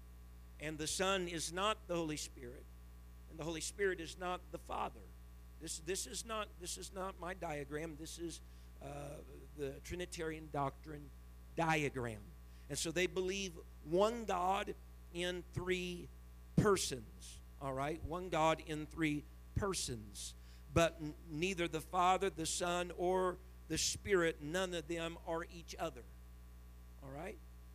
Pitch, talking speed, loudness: 155 Hz, 145 wpm, -40 LUFS